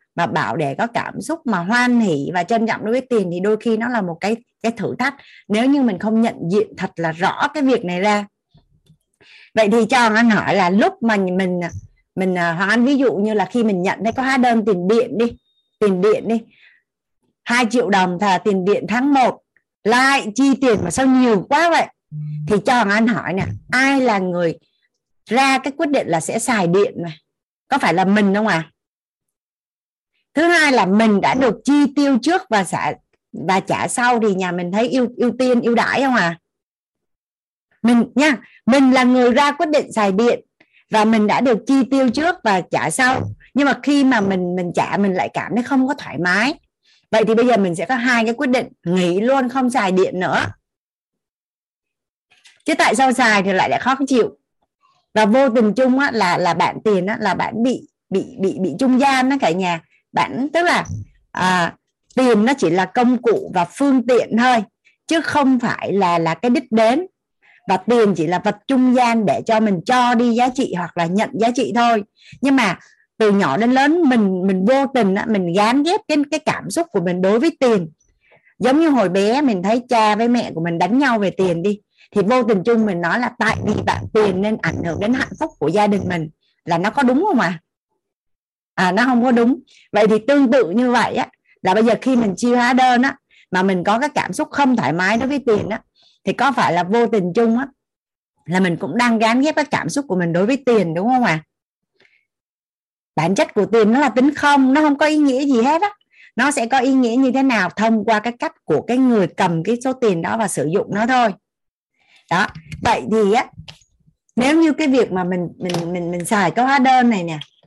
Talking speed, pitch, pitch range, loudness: 225 wpm, 230 Hz, 195-260 Hz, -17 LUFS